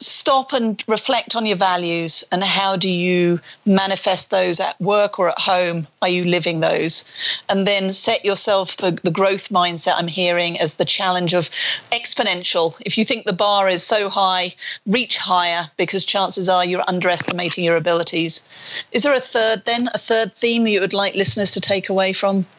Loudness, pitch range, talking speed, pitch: -18 LUFS, 175-205 Hz, 185 wpm, 190 Hz